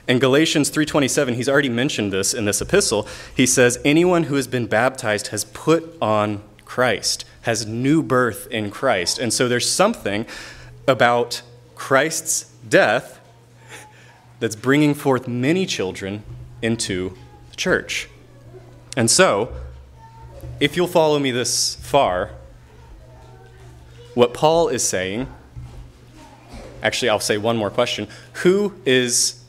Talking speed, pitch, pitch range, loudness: 125 wpm, 120 Hz, 105-140 Hz, -19 LUFS